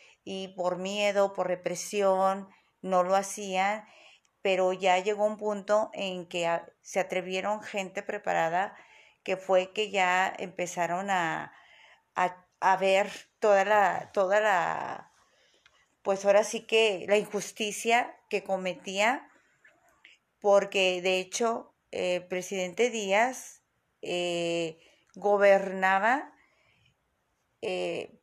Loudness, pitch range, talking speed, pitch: -28 LUFS, 185-210 Hz, 105 wpm, 195 Hz